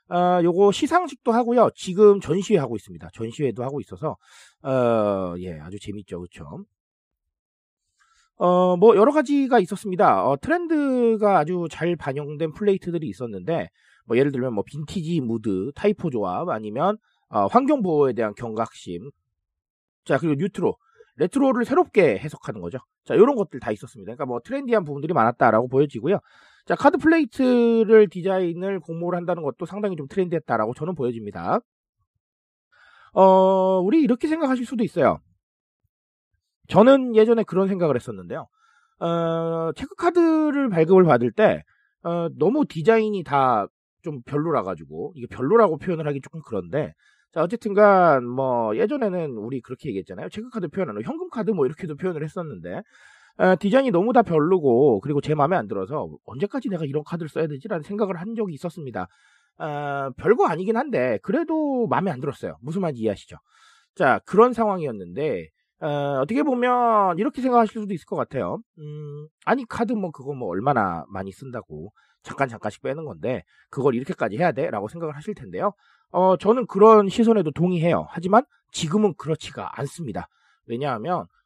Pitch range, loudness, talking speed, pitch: 140-220 Hz, -22 LUFS, 370 characters per minute, 180 Hz